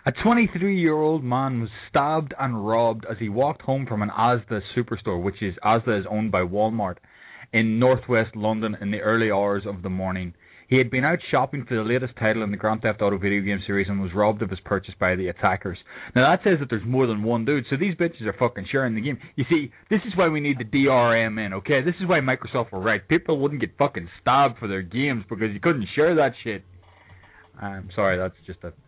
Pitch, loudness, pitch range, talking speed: 110 Hz, -23 LUFS, 100-135 Hz, 235 wpm